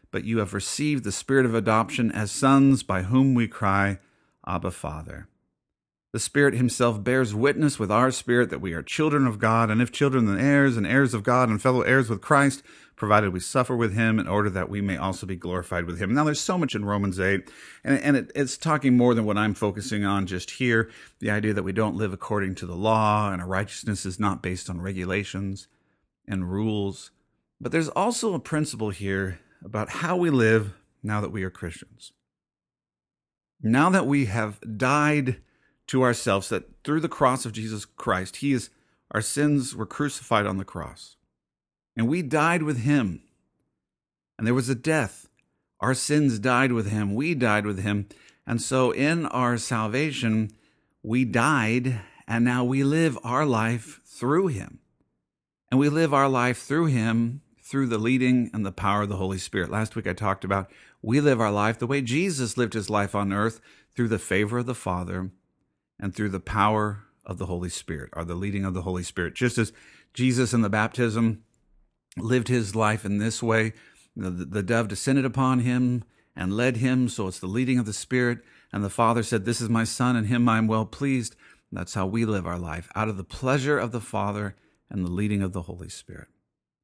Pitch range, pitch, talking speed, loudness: 100-130 Hz, 110 Hz, 200 wpm, -25 LUFS